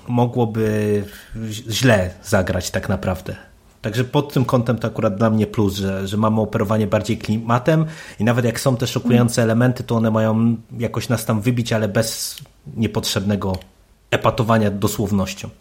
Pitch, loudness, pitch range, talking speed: 110 Hz, -19 LUFS, 105-120 Hz, 150 wpm